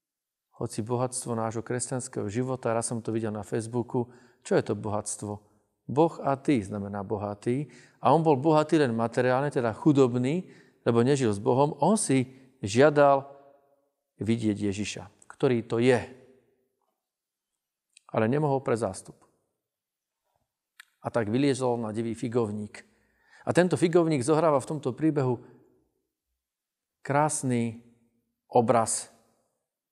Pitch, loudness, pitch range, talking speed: 125 Hz, -27 LUFS, 115-140 Hz, 120 wpm